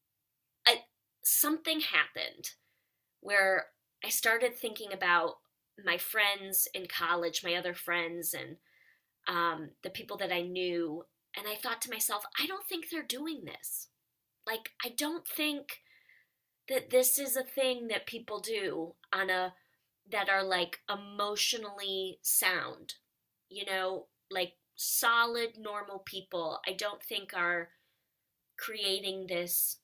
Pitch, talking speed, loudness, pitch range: 200 Hz, 125 wpm, -32 LUFS, 175-235 Hz